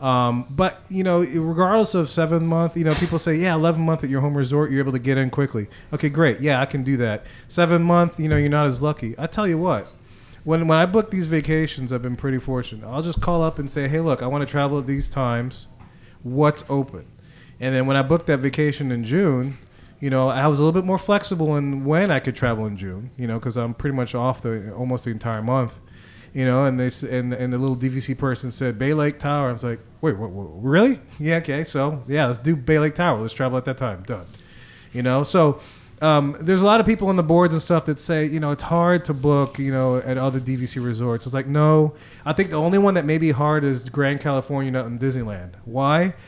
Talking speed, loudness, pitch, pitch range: 245 wpm, -21 LUFS, 140 Hz, 125-160 Hz